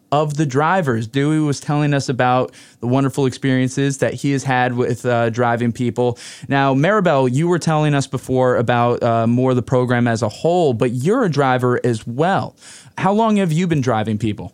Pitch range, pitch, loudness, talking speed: 120-145 Hz, 130 Hz, -17 LUFS, 200 wpm